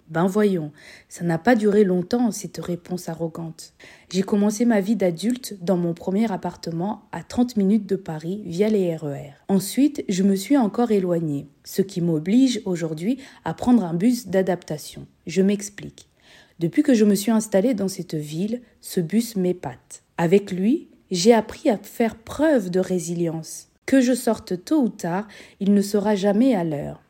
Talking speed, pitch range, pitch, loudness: 170 wpm, 170-225 Hz, 195 Hz, -22 LUFS